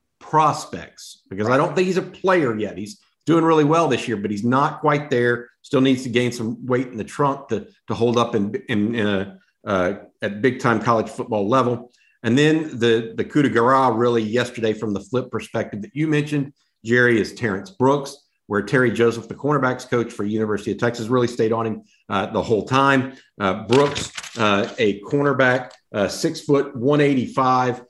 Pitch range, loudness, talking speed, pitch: 115-140 Hz, -20 LUFS, 200 wpm, 125 Hz